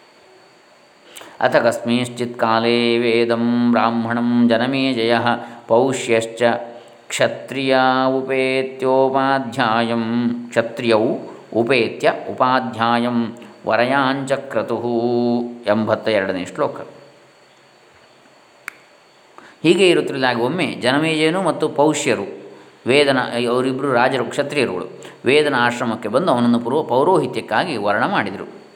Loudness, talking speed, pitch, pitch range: -18 LUFS, 75 wpm, 120 Hz, 115-130 Hz